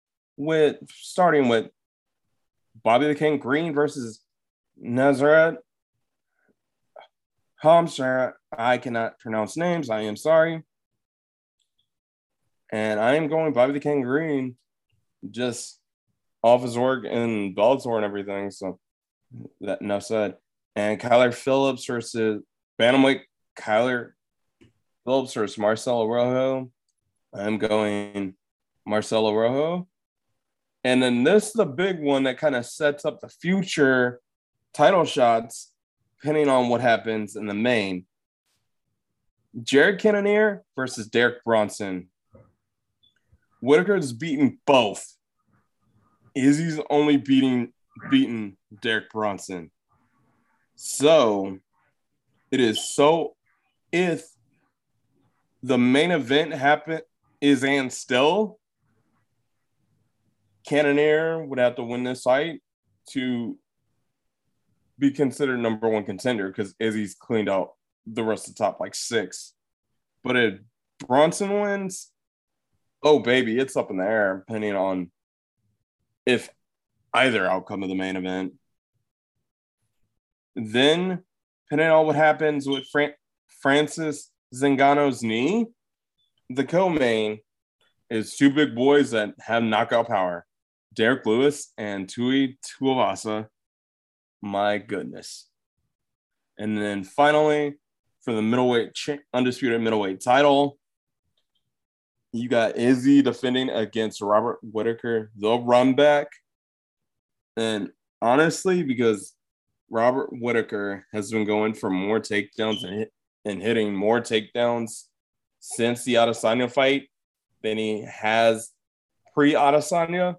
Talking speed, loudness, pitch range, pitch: 110 wpm, -23 LUFS, 110-145 Hz, 120 Hz